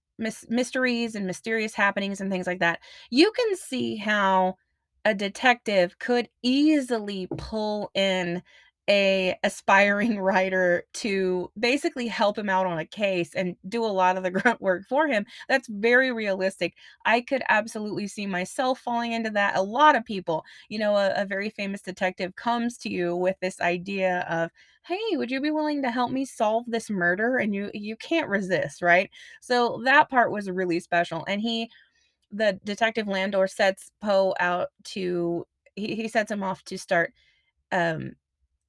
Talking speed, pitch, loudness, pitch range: 165 wpm, 200 Hz, -25 LUFS, 185-235 Hz